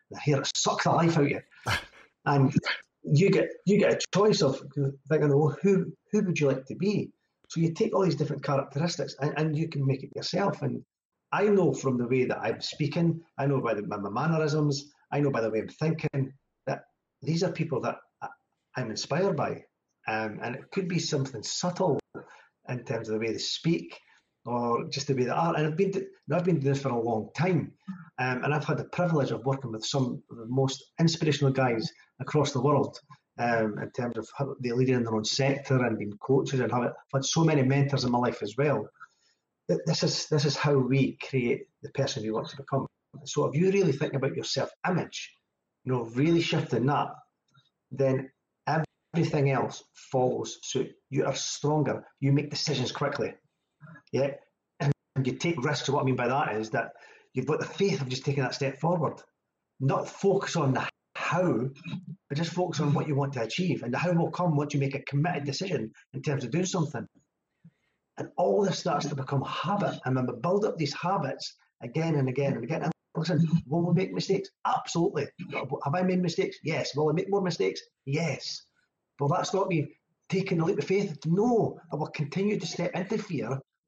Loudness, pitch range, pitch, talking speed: -29 LUFS, 135-170 Hz, 145 Hz, 205 wpm